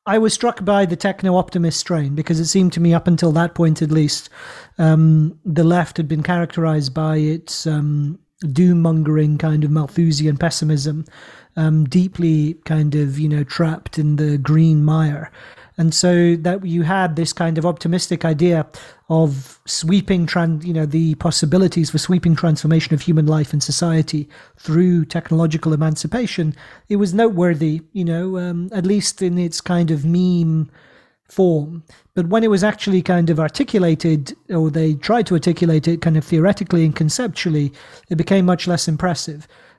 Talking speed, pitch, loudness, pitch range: 165 wpm, 165 Hz, -17 LUFS, 155-180 Hz